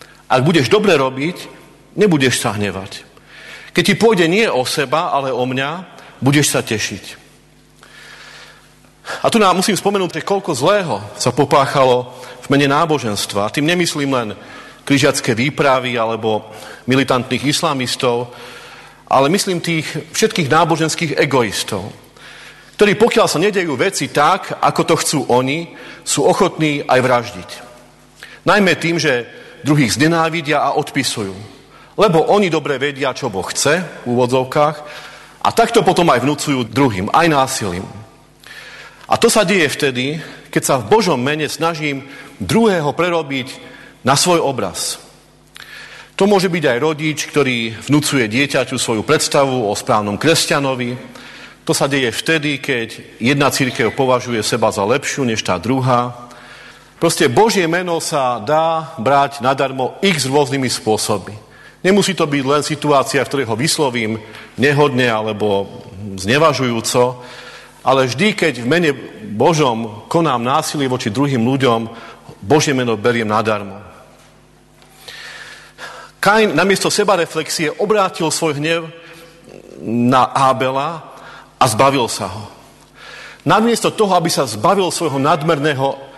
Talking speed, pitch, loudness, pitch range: 125 wpm, 140 Hz, -15 LUFS, 125-165 Hz